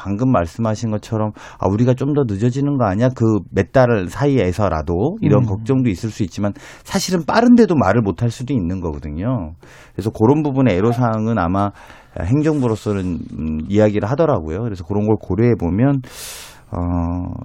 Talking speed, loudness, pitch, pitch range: 360 characters per minute, -18 LUFS, 110 Hz, 95-130 Hz